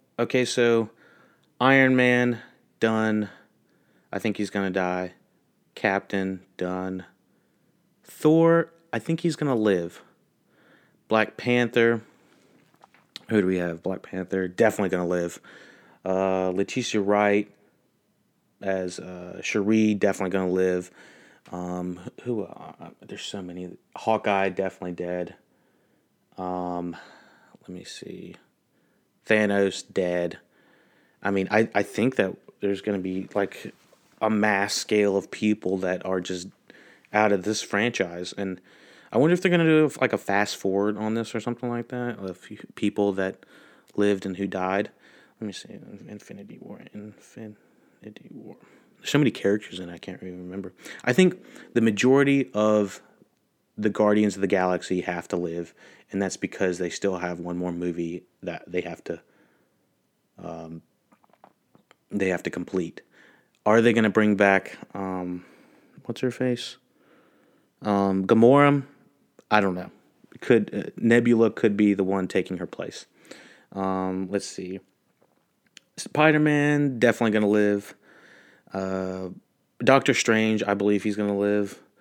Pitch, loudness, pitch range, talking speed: 100 Hz, -24 LUFS, 95-115 Hz, 140 wpm